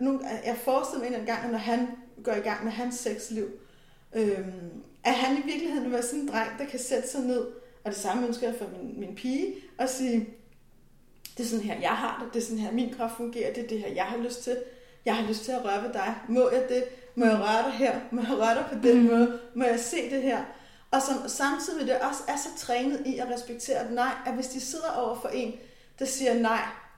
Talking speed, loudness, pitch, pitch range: 250 wpm, -29 LUFS, 245 Hz, 230-260 Hz